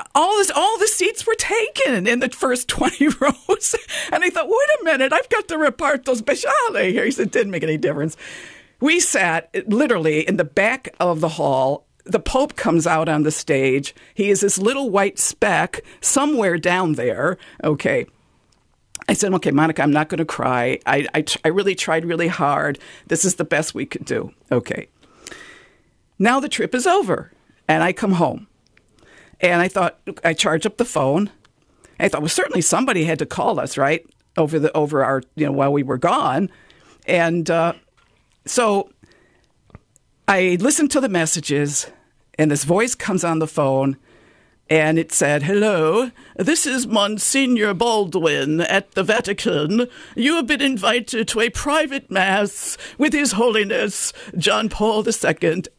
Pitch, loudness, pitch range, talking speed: 200 Hz, -19 LUFS, 160-260 Hz, 170 wpm